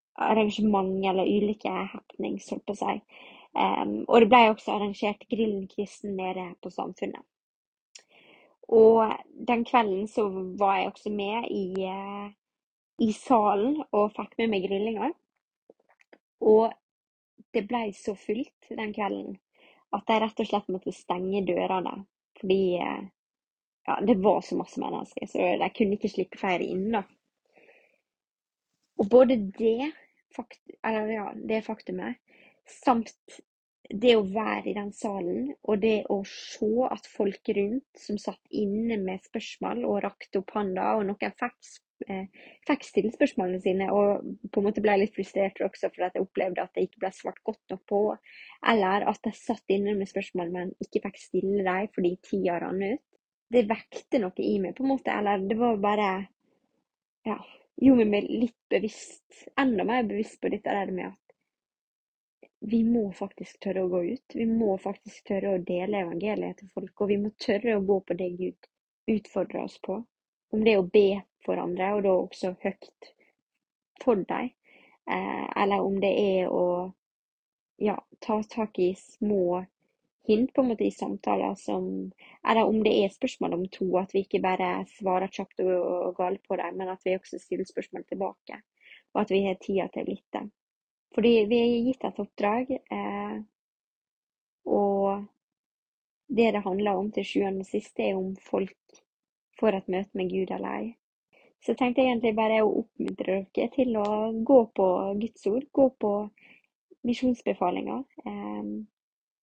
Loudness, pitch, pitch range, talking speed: -28 LUFS, 205 Hz, 190-230 Hz, 165 wpm